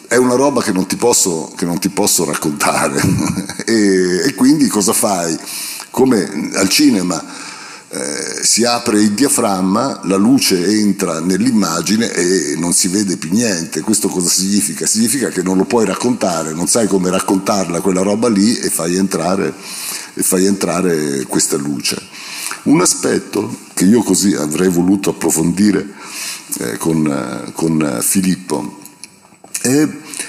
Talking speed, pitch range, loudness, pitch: 145 wpm, 90-100 Hz, -14 LUFS, 95 Hz